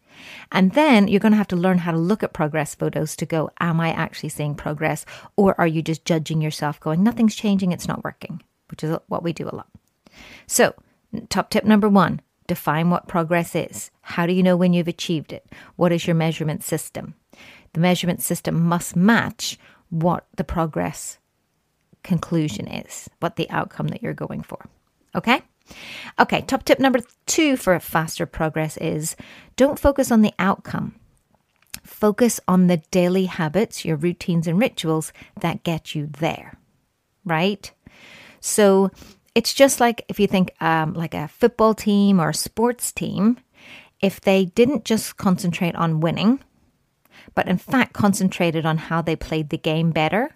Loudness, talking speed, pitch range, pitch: -21 LUFS, 170 wpm, 160-205 Hz, 175 Hz